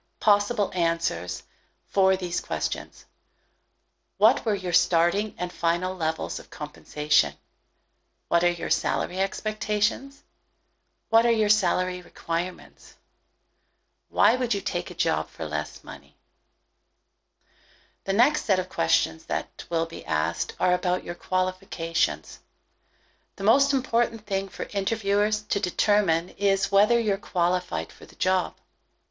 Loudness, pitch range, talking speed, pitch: -25 LUFS, 170-205 Hz, 125 wpm, 185 Hz